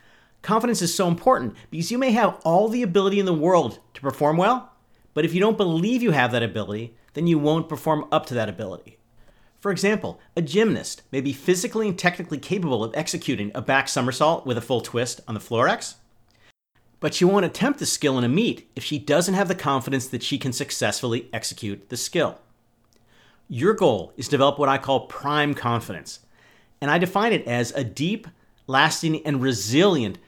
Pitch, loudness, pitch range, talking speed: 145 Hz, -23 LUFS, 120-180 Hz, 195 wpm